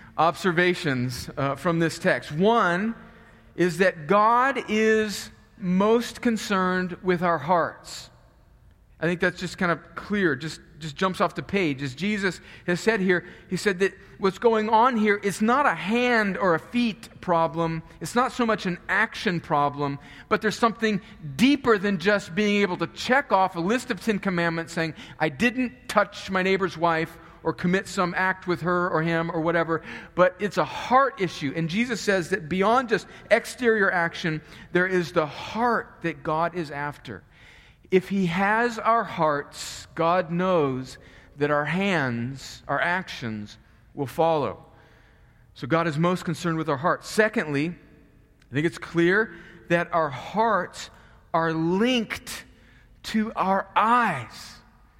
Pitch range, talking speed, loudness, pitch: 165-210 Hz, 155 wpm, -24 LUFS, 180 Hz